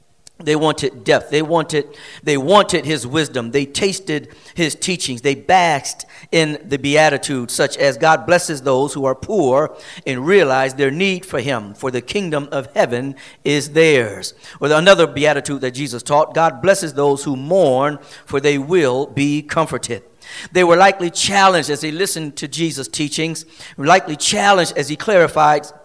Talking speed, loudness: 165 wpm, -16 LUFS